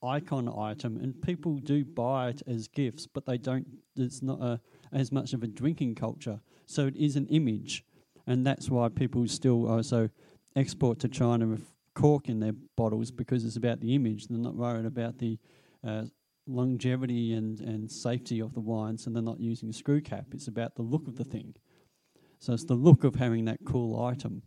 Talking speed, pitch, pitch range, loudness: 200 wpm, 120 Hz, 115-135 Hz, -31 LUFS